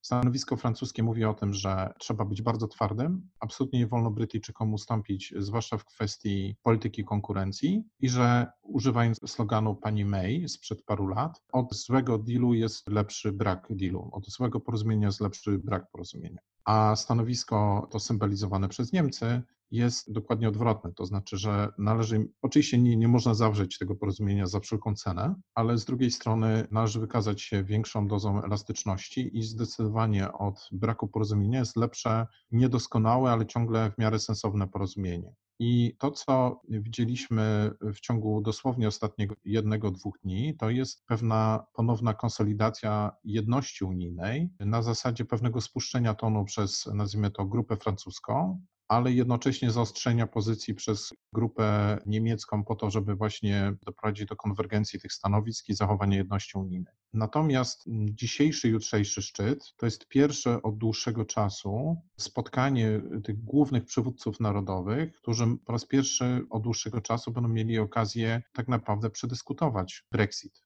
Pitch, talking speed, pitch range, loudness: 110 Hz, 140 wpm, 105-120 Hz, -29 LUFS